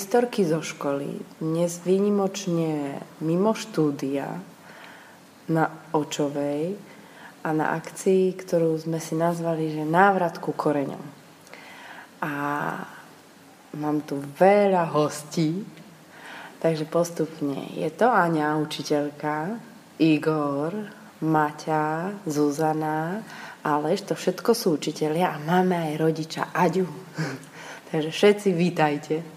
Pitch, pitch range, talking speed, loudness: 160 Hz, 150-180 Hz, 95 wpm, -25 LUFS